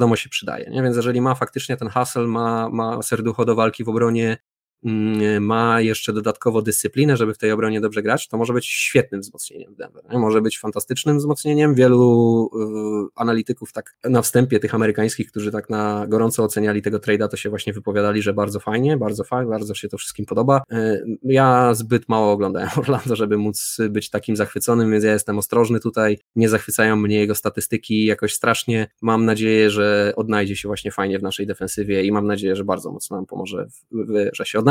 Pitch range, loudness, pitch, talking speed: 105-115 Hz, -20 LUFS, 110 Hz, 195 wpm